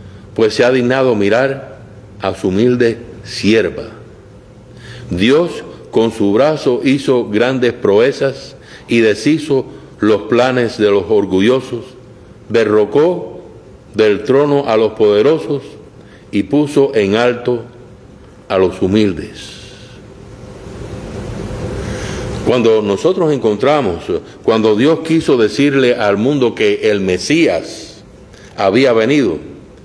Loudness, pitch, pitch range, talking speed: -13 LUFS, 115 Hz, 100-130 Hz, 100 wpm